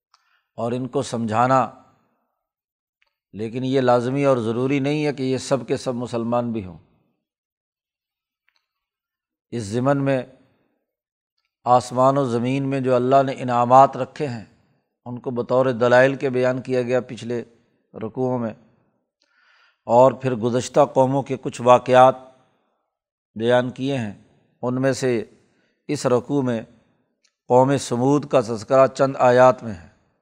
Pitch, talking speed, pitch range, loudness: 125 Hz, 135 wpm, 120-135 Hz, -20 LUFS